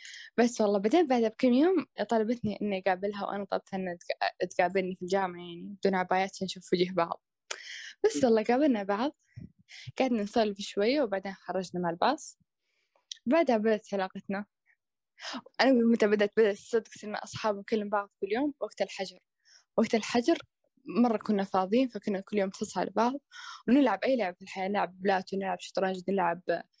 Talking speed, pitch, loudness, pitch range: 150 wpm, 205 Hz, -30 LUFS, 190-240 Hz